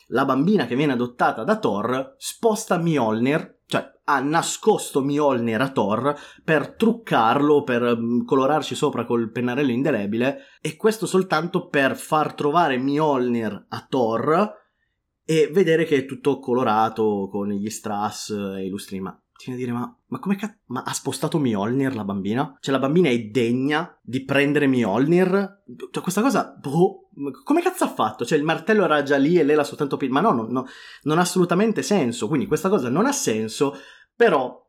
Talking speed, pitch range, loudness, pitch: 170 wpm, 120-170 Hz, -22 LUFS, 140 Hz